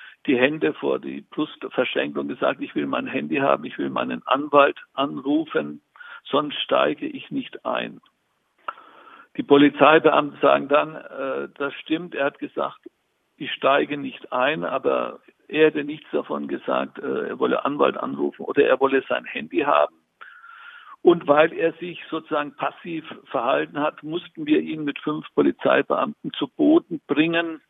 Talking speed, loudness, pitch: 155 wpm, -22 LUFS, 170 Hz